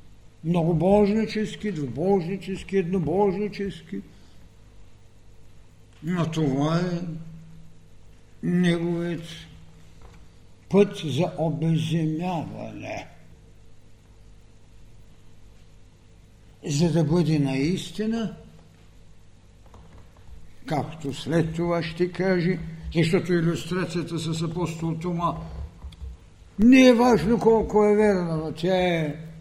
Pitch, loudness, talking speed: 160 Hz, -24 LUFS, 65 wpm